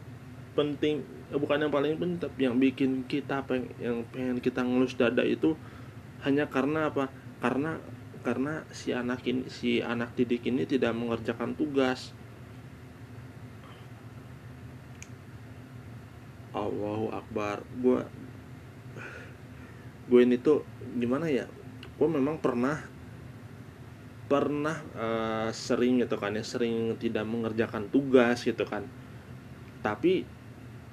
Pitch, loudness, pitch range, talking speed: 125 Hz, -29 LUFS, 120-130 Hz, 105 wpm